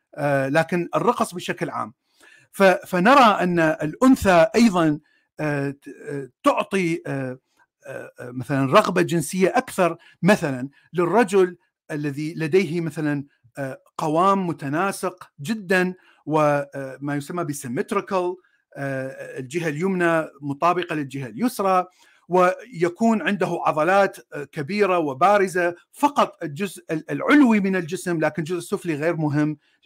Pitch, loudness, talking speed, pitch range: 175 Hz, -21 LUFS, 90 wpm, 150-190 Hz